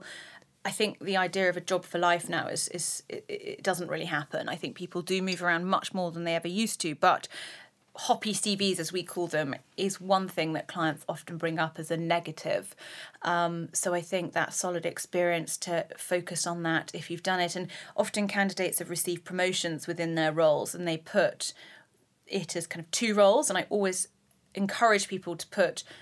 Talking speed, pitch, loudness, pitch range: 205 wpm, 180 Hz, -29 LUFS, 170-195 Hz